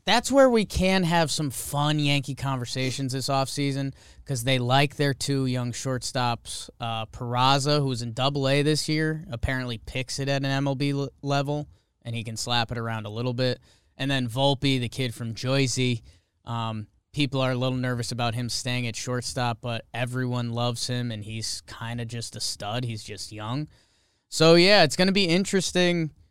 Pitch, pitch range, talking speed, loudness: 130 Hz, 115-140 Hz, 185 wpm, -25 LUFS